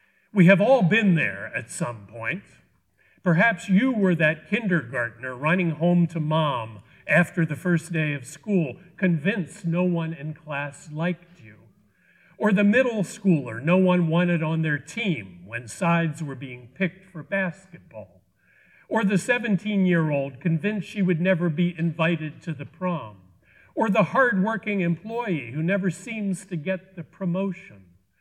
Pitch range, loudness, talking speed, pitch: 155-190 Hz, -24 LUFS, 150 wpm, 175 Hz